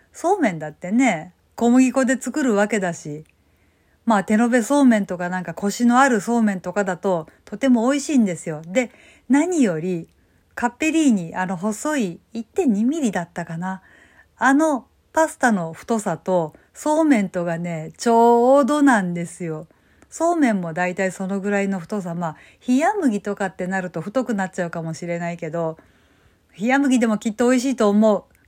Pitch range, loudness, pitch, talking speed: 175-255 Hz, -20 LUFS, 210 Hz, 335 characters per minute